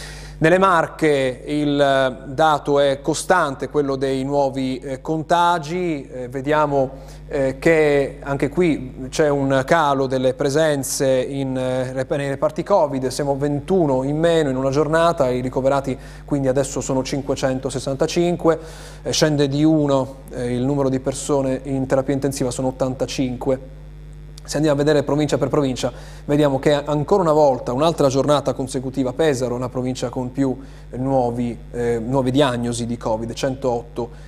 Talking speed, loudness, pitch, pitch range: 145 wpm, -20 LUFS, 140 Hz, 130-150 Hz